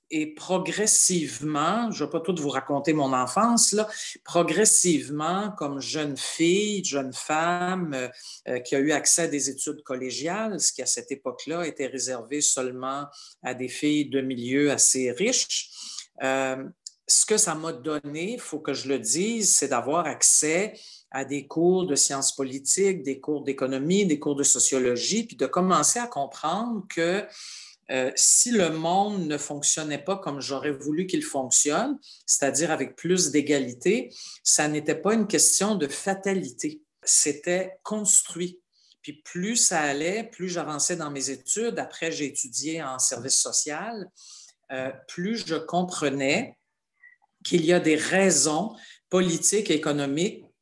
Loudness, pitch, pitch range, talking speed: -24 LUFS, 155 Hz, 140-185 Hz, 155 wpm